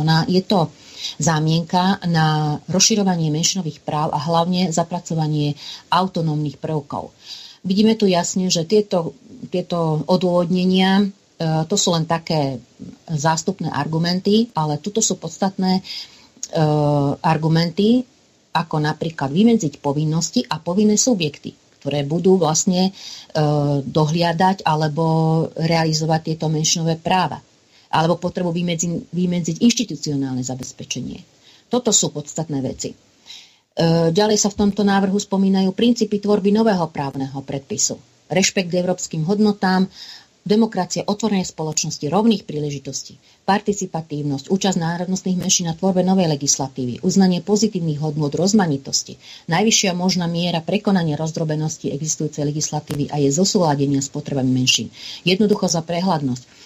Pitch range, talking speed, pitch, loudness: 155-190 Hz, 110 wpm, 170 Hz, -19 LUFS